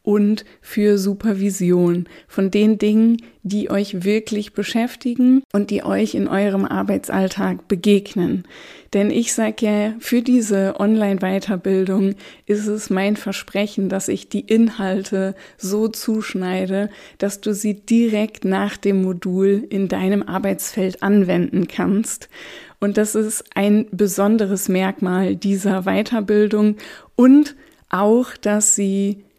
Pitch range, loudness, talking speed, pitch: 195-215 Hz, -19 LUFS, 120 wpm, 205 Hz